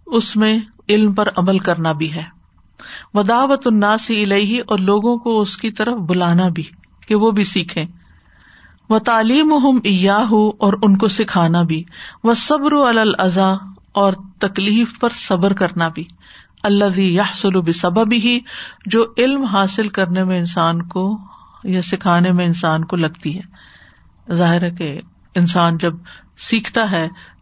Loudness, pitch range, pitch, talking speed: -16 LUFS, 175-220 Hz, 195 Hz, 140 wpm